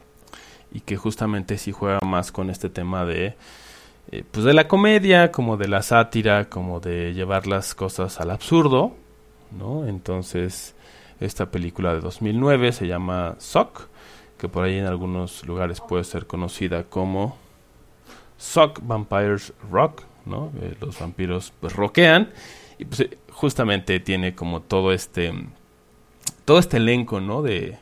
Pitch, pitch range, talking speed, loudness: 95 Hz, 90-110 Hz, 145 wpm, -22 LUFS